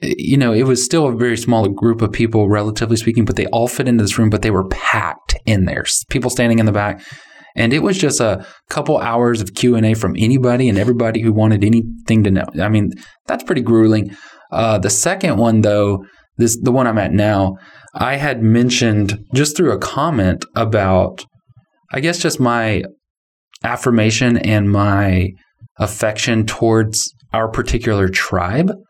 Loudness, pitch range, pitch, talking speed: -15 LUFS, 105-120 Hz, 110 Hz, 180 wpm